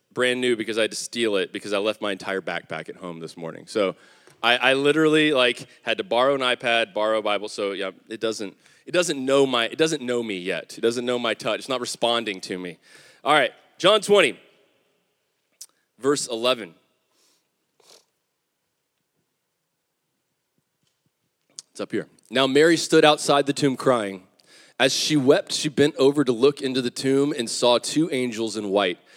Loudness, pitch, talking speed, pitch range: -22 LUFS, 120 Hz, 180 wpm, 105-140 Hz